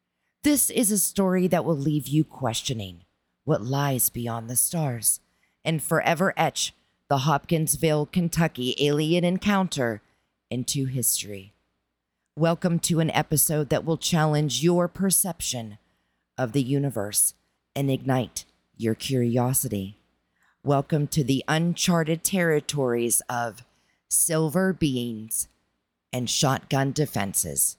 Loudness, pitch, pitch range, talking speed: -24 LUFS, 140 Hz, 120-165 Hz, 110 wpm